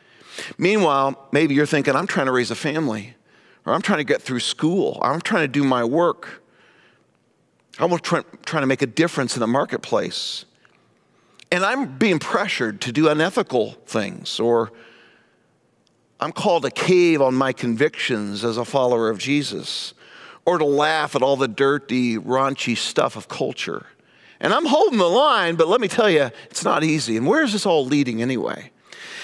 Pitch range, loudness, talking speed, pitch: 120-160 Hz, -20 LUFS, 175 wpm, 140 Hz